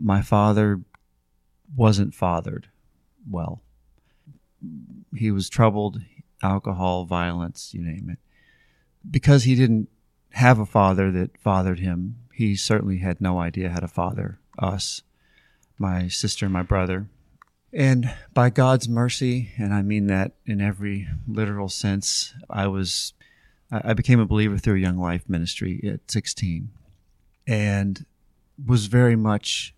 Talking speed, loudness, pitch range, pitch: 130 wpm, -23 LUFS, 90-115 Hz, 100 Hz